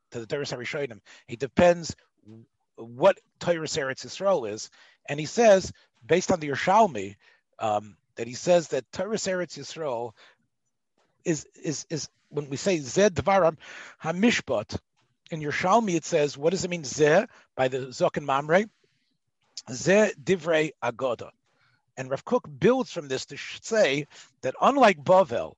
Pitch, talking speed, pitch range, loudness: 160 Hz, 140 wpm, 135-185 Hz, -25 LUFS